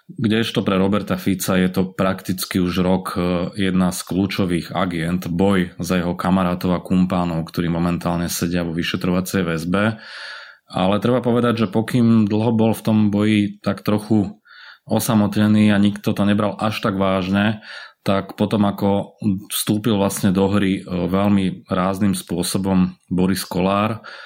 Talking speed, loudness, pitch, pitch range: 145 wpm, -19 LUFS, 95 Hz, 90-105 Hz